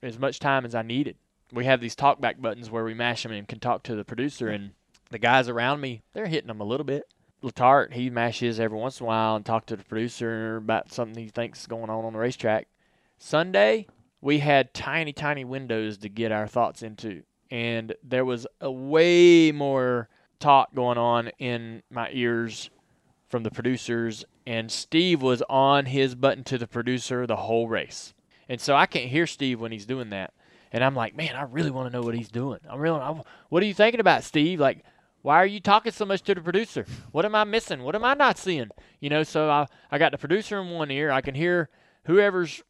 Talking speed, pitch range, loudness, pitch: 225 wpm, 115-150 Hz, -25 LUFS, 125 Hz